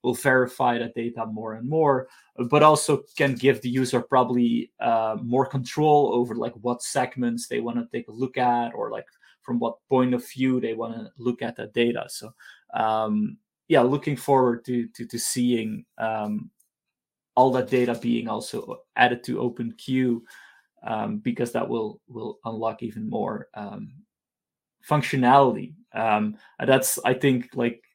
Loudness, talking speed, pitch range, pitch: -24 LUFS, 165 wpm, 120-130 Hz, 125 Hz